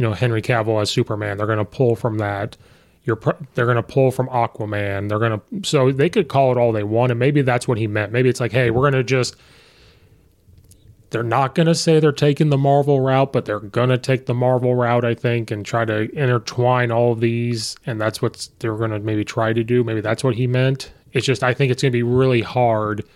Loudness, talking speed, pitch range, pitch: -19 LUFS, 250 wpm, 110-130 Hz, 120 Hz